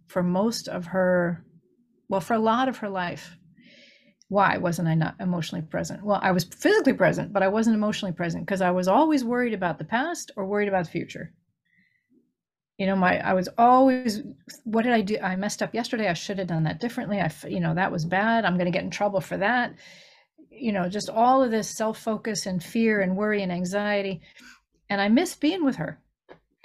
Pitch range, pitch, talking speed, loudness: 180-230 Hz, 200 Hz, 210 wpm, -25 LUFS